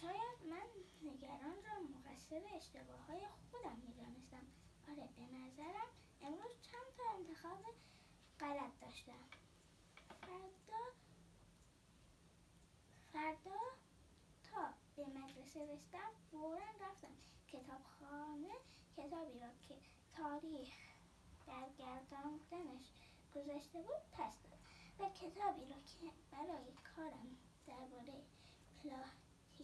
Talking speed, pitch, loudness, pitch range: 95 wpm, 305 Hz, -53 LUFS, 275-375 Hz